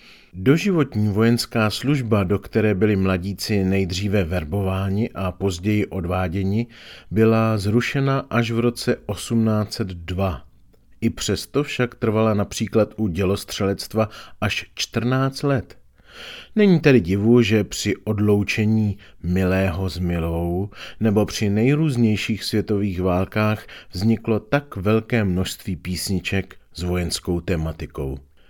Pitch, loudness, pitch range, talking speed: 105 Hz, -21 LUFS, 95-115 Hz, 105 wpm